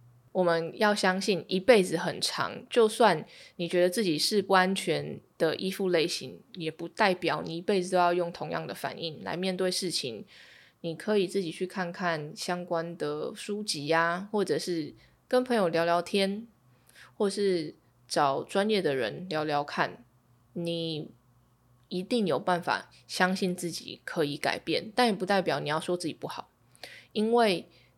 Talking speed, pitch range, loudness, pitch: 235 characters per minute, 160-195 Hz, -29 LUFS, 175 Hz